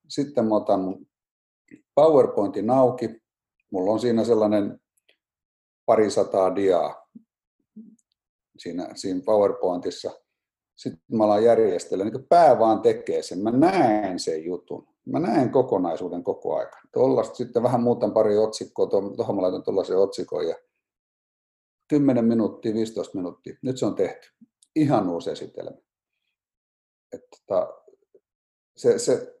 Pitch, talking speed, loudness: 145 Hz, 115 wpm, -23 LUFS